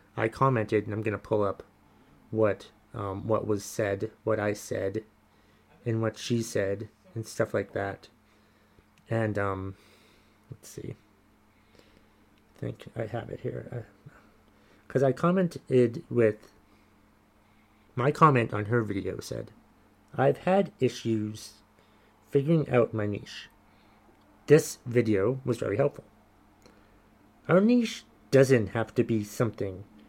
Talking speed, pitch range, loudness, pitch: 130 wpm, 105-120 Hz, -28 LUFS, 110 Hz